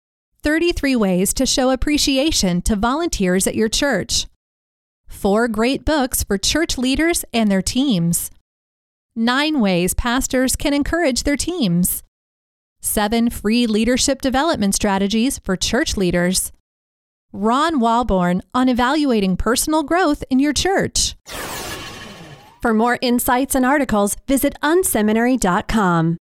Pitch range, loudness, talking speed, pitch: 185-275 Hz, -18 LUFS, 115 wpm, 235 Hz